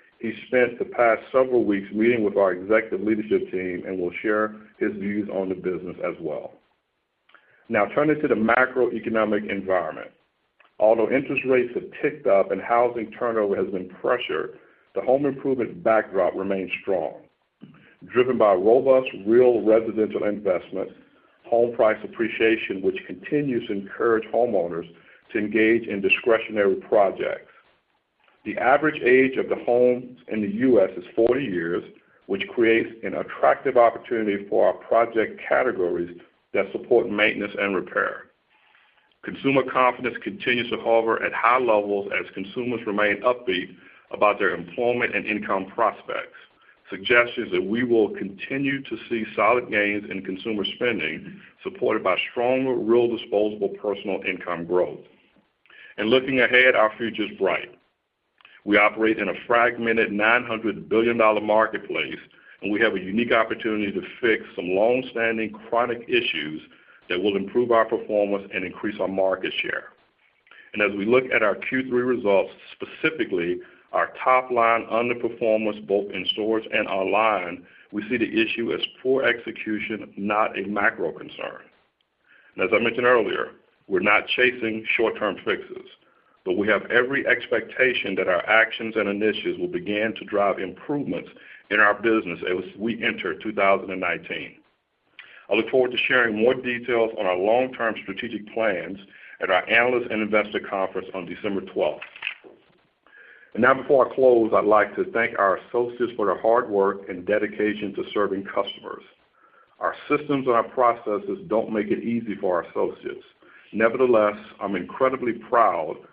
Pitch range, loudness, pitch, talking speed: 105-125 Hz, -23 LUFS, 115 Hz, 145 wpm